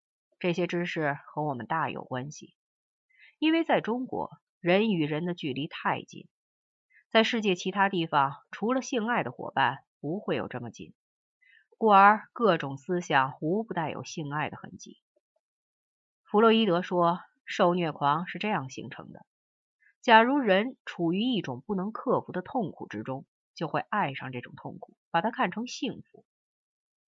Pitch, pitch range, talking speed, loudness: 180 Hz, 150-220 Hz, 230 characters per minute, -28 LUFS